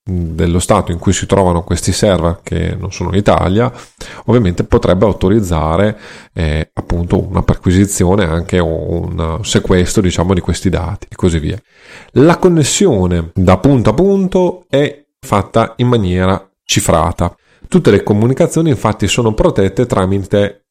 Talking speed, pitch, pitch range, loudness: 140 wpm, 95 Hz, 90-115 Hz, -13 LUFS